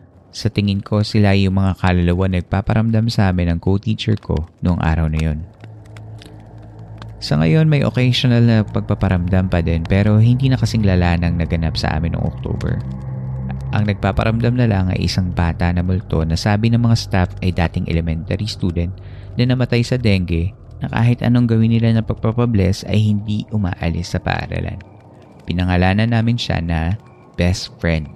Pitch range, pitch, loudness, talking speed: 90-110 Hz, 100 Hz, -18 LUFS, 160 wpm